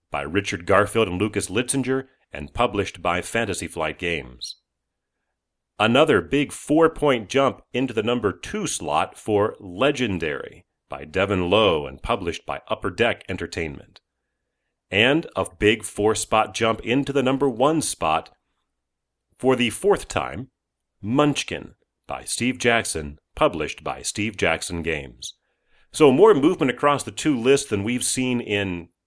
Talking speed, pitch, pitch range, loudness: 140 wpm, 105 Hz, 85-125 Hz, -22 LUFS